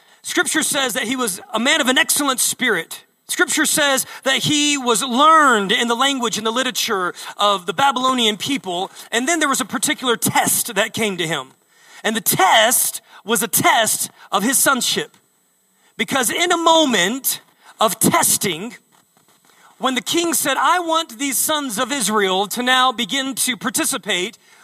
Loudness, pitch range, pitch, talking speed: -17 LUFS, 225-290 Hz, 260 Hz, 165 wpm